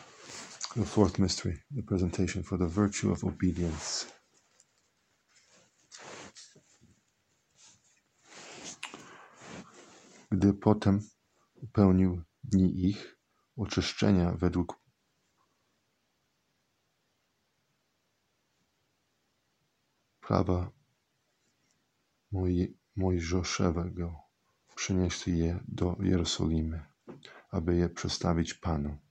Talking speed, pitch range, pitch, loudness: 55 wpm, 85-100 Hz, 90 Hz, -31 LUFS